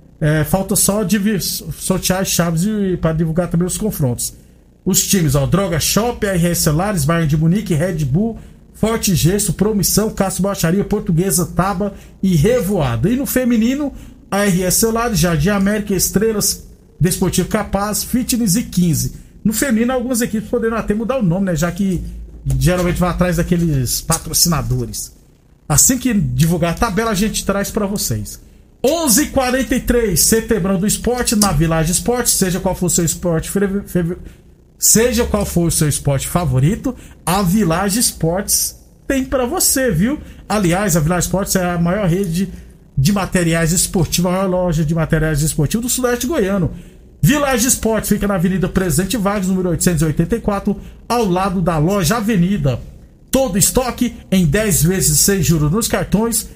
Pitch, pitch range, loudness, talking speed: 190 Hz, 170-215 Hz, -16 LUFS, 155 wpm